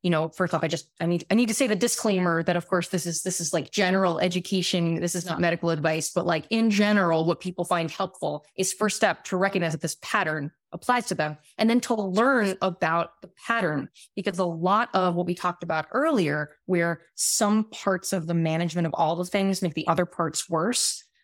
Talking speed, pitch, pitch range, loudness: 225 wpm, 180 Hz, 165-200 Hz, -25 LUFS